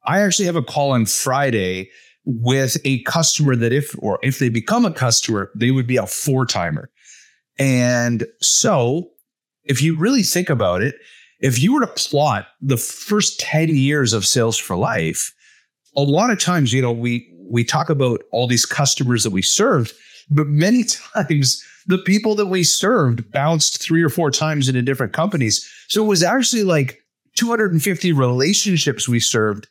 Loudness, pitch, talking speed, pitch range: -17 LUFS, 140 Hz, 175 wpm, 120-175 Hz